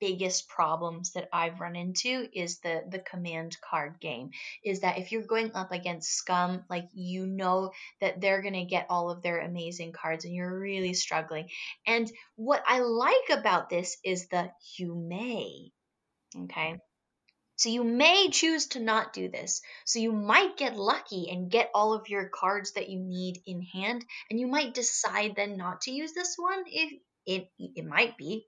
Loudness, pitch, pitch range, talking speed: -30 LUFS, 190 Hz, 175-225 Hz, 185 wpm